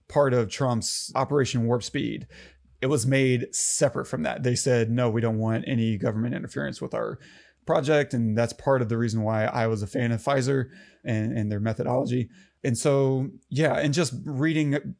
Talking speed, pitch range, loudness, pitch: 190 wpm, 115-135 Hz, -25 LUFS, 125 Hz